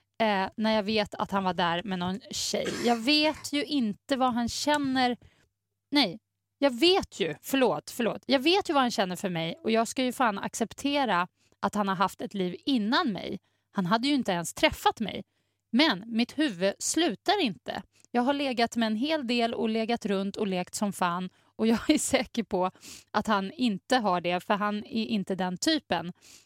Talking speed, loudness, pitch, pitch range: 195 wpm, -28 LUFS, 225 Hz, 195-270 Hz